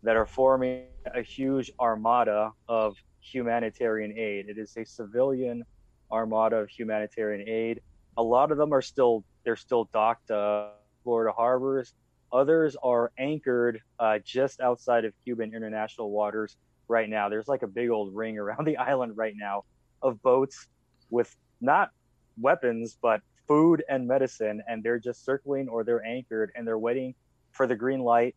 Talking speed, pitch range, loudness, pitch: 160 wpm, 110-130 Hz, -28 LUFS, 115 Hz